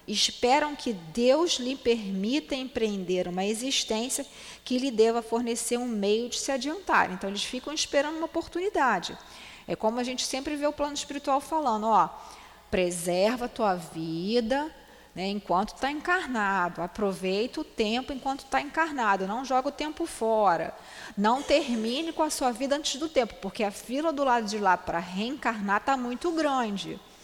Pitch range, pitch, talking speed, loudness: 205-285 Hz, 245 Hz, 165 wpm, -28 LUFS